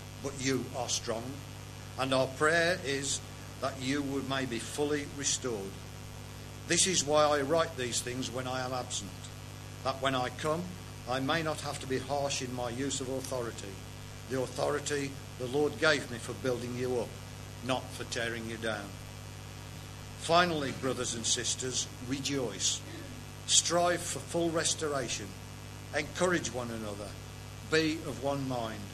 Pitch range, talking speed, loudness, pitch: 110-140 Hz, 150 wpm, -32 LUFS, 125 Hz